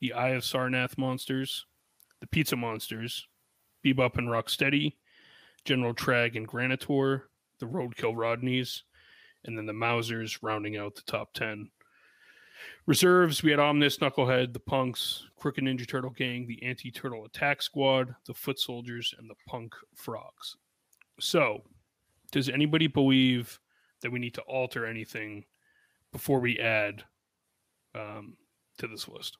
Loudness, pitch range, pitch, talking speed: -29 LUFS, 115-135 Hz, 125 Hz, 135 wpm